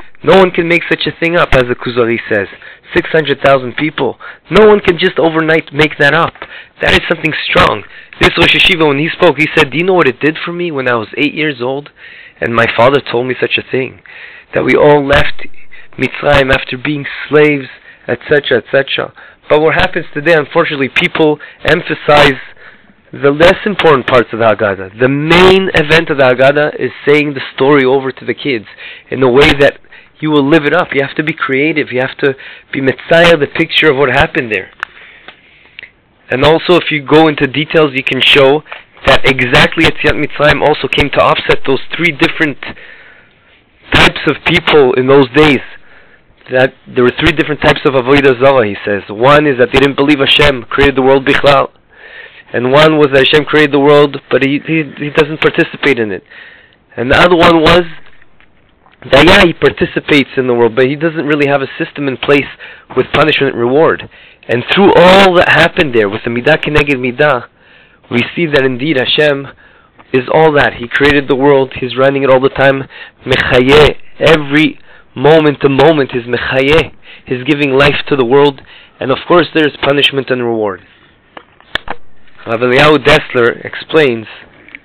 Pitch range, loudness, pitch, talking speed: 135-160 Hz, -10 LUFS, 145 Hz, 185 wpm